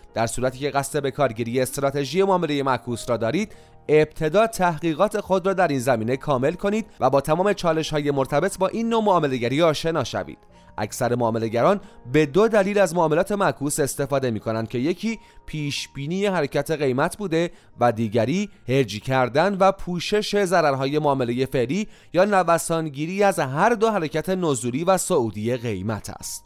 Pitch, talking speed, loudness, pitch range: 150 Hz, 155 wpm, -22 LUFS, 130-190 Hz